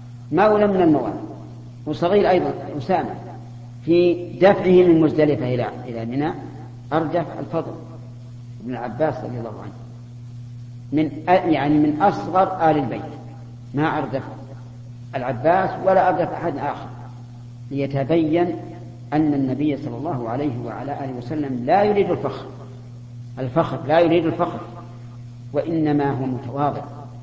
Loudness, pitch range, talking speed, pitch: -20 LUFS, 120-155 Hz, 115 wpm, 135 Hz